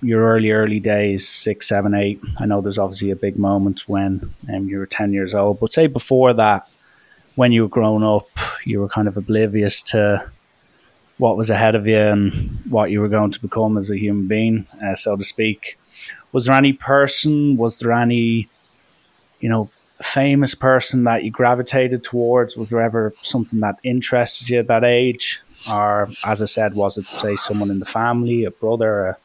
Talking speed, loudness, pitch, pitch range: 195 wpm, -18 LUFS, 110 Hz, 100-120 Hz